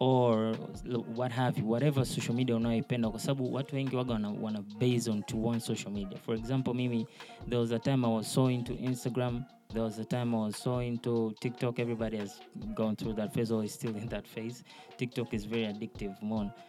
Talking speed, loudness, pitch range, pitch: 225 wpm, -33 LUFS, 110-125 Hz, 115 Hz